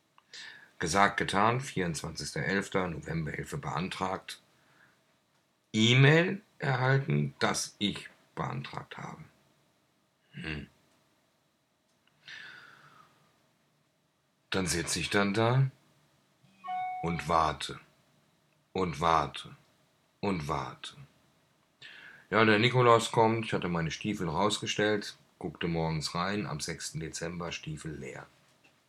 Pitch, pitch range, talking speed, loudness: 110 Hz, 85-130 Hz, 85 wpm, -30 LUFS